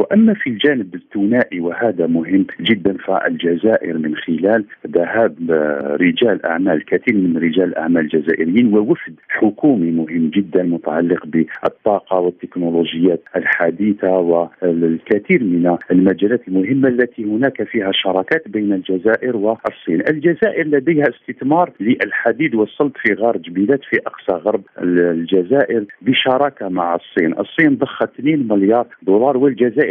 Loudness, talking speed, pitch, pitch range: -16 LUFS, 115 wpm, 95 Hz, 85-120 Hz